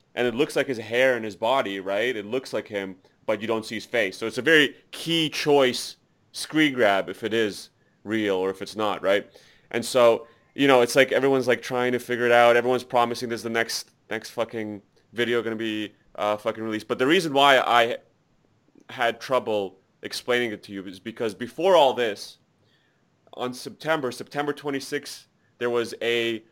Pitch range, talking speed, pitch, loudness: 110-130 Hz, 195 wpm, 120 Hz, -24 LUFS